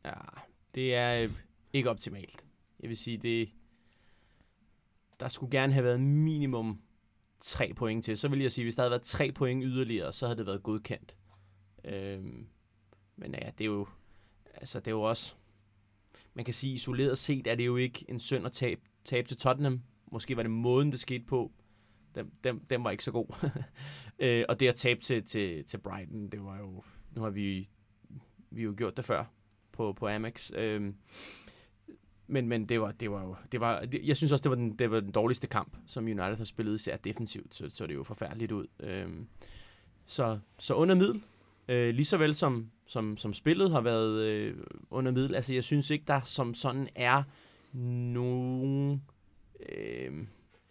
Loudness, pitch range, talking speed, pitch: -32 LUFS, 105-130 Hz, 190 wpm, 115 Hz